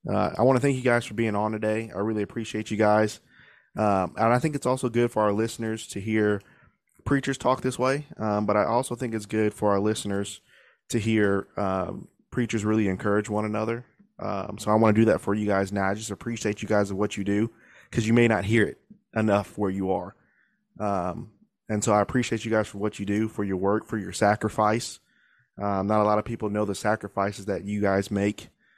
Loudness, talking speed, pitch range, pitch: -26 LUFS, 230 wpm, 100-115 Hz, 105 Hz